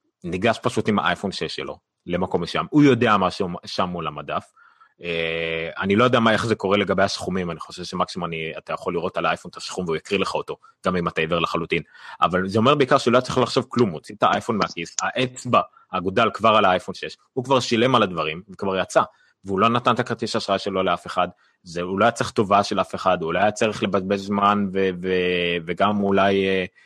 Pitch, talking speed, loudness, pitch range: 100 Hz, 220 wpm, -22 LUFS, 90-115 Hz